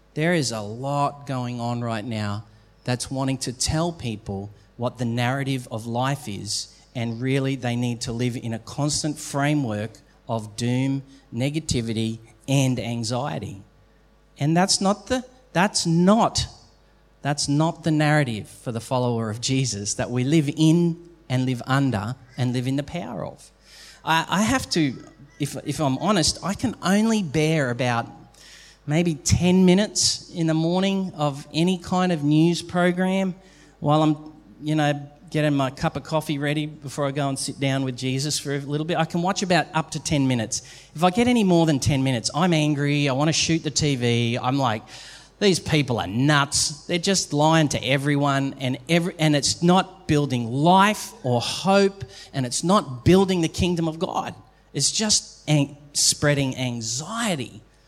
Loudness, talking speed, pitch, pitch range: -23 LUFS, 170 wpm, 145 Hz, 125-165 Hz